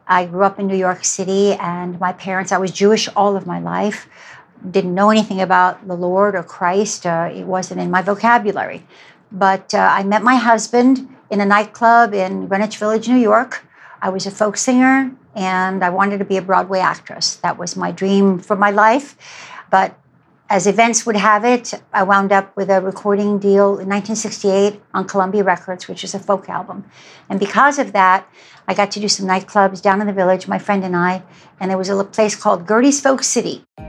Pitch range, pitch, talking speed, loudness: 190-215 Hz, 200 Hz, 205 wpm, -16 LUFS